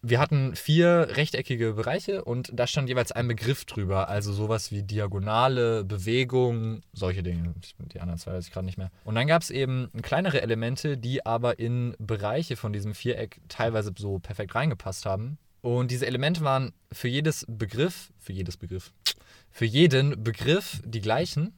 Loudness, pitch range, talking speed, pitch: -27 LUFS, 105-135 Hz, 170 wpm, 120 Hz